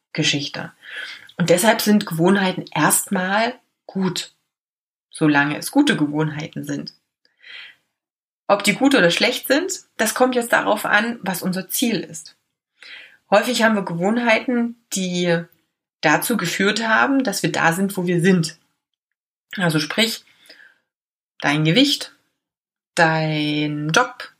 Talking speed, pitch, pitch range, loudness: 120 wpm, 190 Hz, 165-225 Hz, -19 LUFS